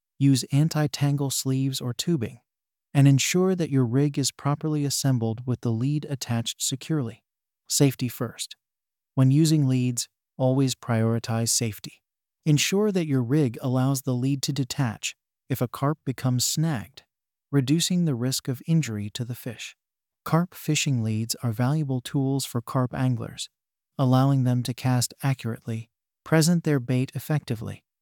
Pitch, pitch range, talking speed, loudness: 130 Hz, 125-145 Hz, 145 wpm, -25 LUFS